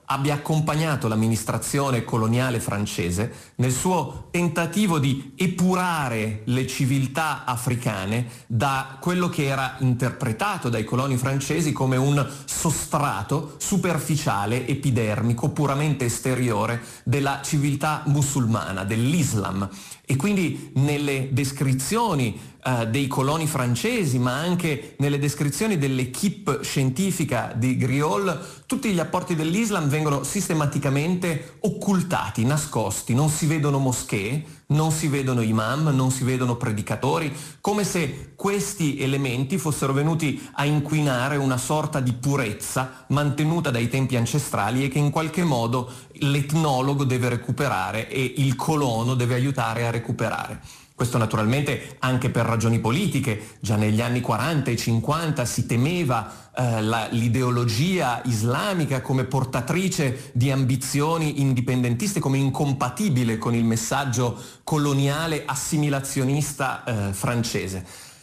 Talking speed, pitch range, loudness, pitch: 115 wpm, 125-150 Hz, -23 LUFS, 135 Hz